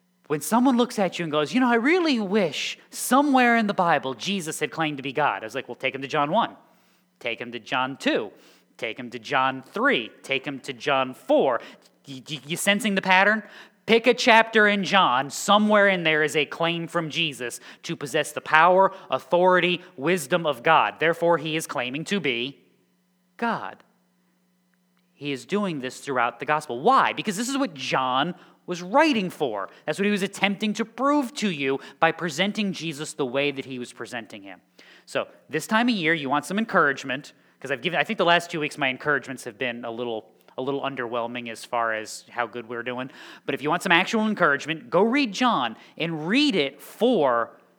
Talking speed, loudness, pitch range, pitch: 205 wpm, -23 LUFS, 135-200 Hz, 160 Hz